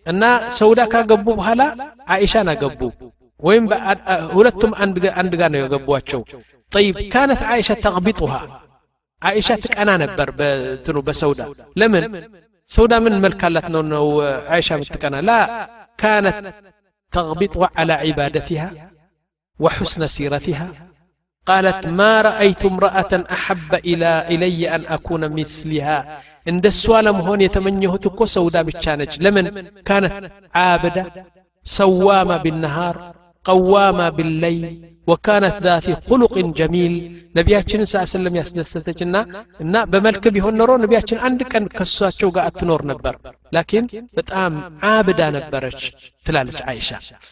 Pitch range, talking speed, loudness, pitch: 160-205 Hz, 110 wpm, -17 LUFS, 180 Hz